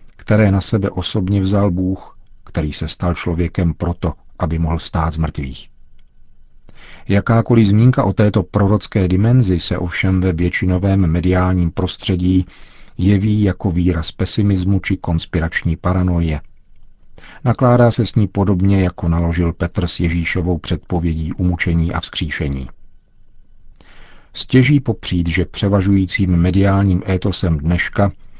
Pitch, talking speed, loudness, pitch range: 90 Hz, 120 wpm, -16 LUFS, 85-100 Hz